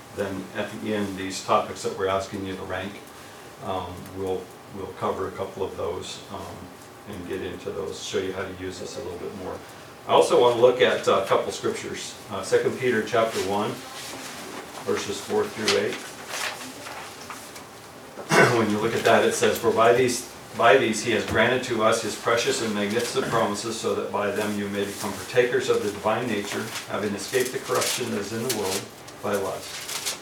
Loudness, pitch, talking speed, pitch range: -25 LUFS, 105 Hz, 195 wpm, 95-125 Hz